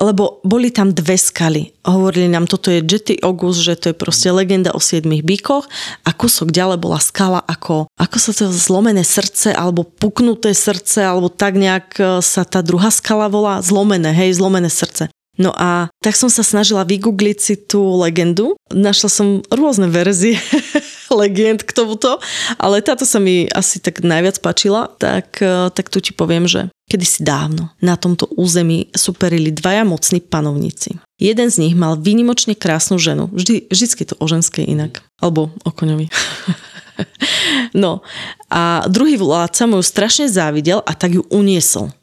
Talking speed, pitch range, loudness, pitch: 160 wpm, 175-210 Hz, -14 LUFS, 190 Hz